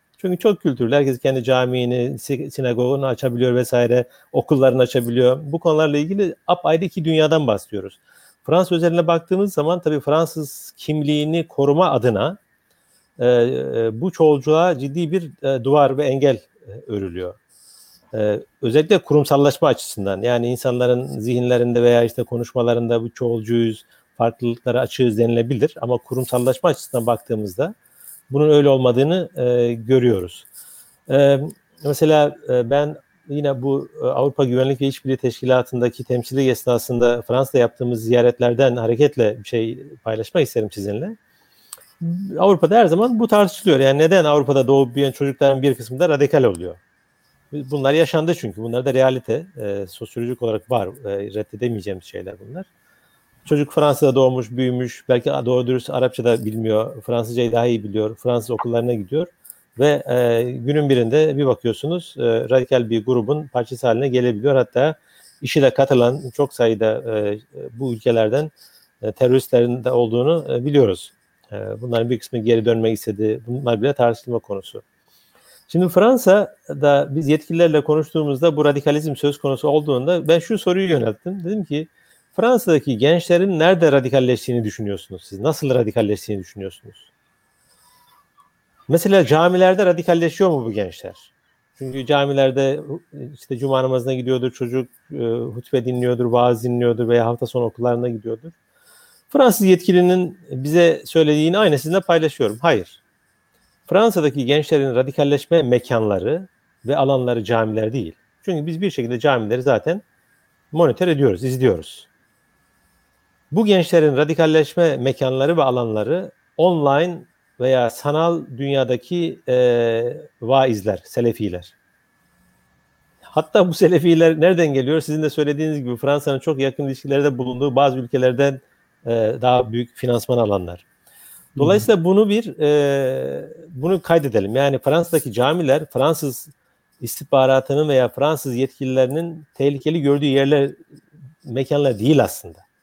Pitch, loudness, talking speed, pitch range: 135 Hz, -18 LUFS, 125 wpm, 120-155 Hz